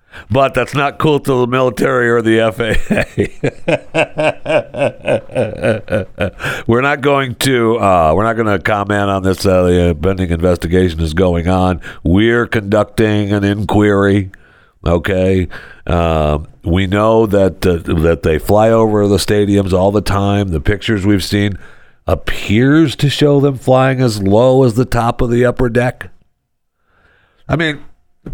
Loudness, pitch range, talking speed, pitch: -13 LUFS, 95-120 Hz, 145 wpm, 105 Hz